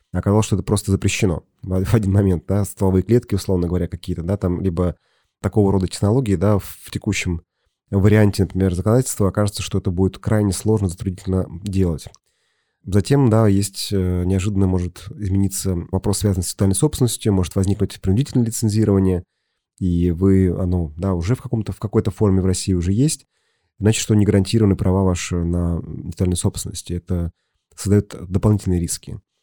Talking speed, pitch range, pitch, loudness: 155 wpm, 90-105 Hz, 95 Hz, -20 LUFS